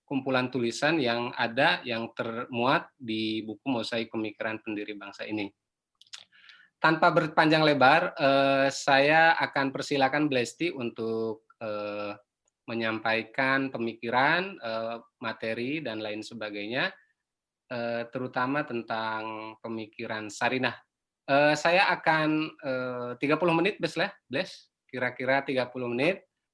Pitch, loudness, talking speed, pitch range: 125 Hz, -27 LUFS, 90 wpm, 110-140 Hz